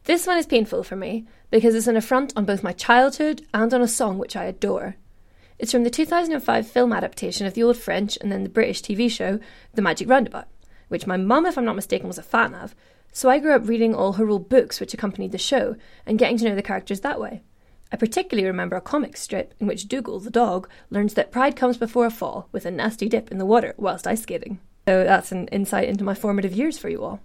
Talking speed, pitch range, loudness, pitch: 245 wpm, 200-250 Hz, -22 LUFS, 230 Hz